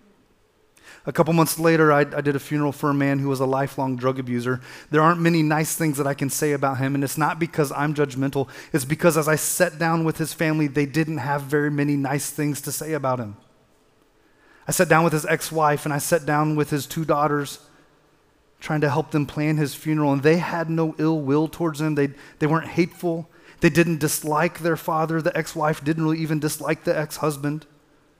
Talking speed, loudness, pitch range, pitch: 220 wpm, -22 LUFS, 145-160 Hz, 150 Hz